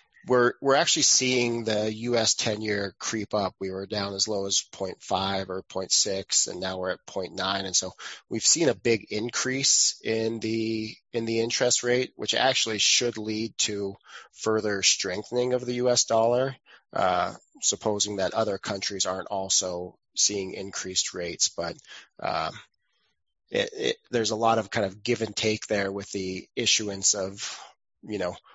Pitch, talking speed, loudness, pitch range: 110 Hz, 160 wpm, -25 LUFS, 100-120 Hz